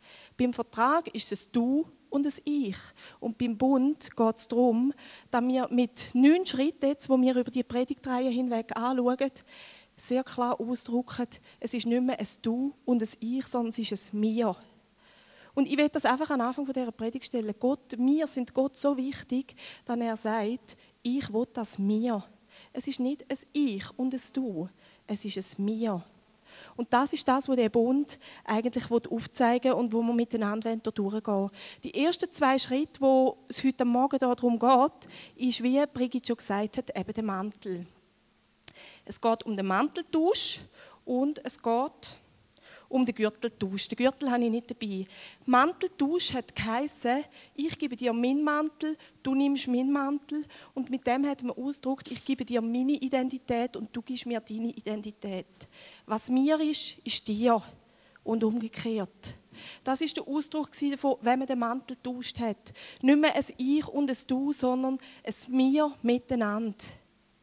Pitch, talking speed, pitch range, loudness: 250 Hz, 170 wpm, 225-270 Hz, -29 LUFS